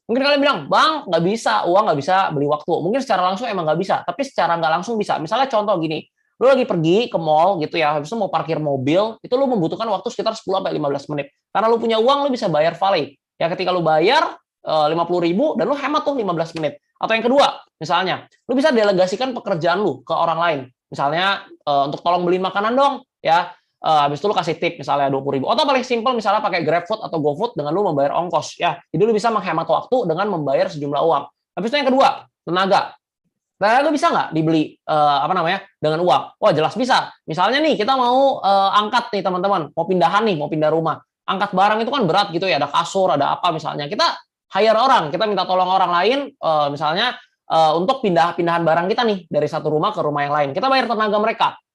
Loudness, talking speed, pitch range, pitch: -18 LUFS, 215 wpm, 160-235 Hz, 190 Hz